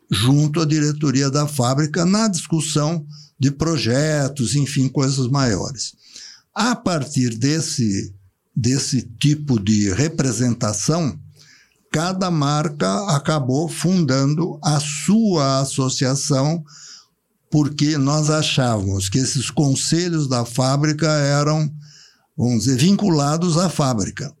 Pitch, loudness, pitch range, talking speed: 145 Hz, -19 LUFS, 130-160 Hz, 100 wpm